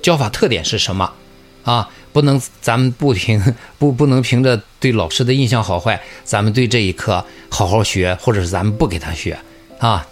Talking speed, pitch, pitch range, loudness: 275 characters per minute, 110 Hz, 90-130 Hz, -16 LUFS